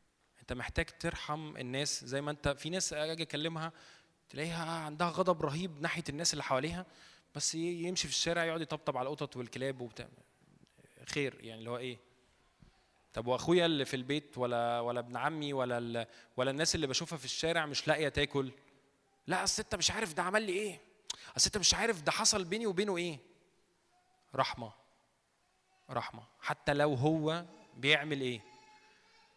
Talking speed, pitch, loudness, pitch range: 155 wpm, 150 Hz, -34 LUFS, 135-170 Hz